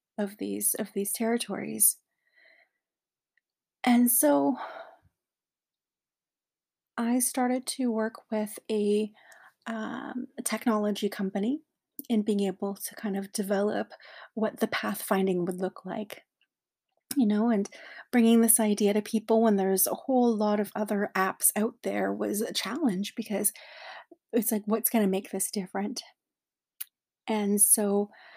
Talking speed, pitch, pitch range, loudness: 130 wpm, 215 Hz, 205-235 Hz, -27 LUFS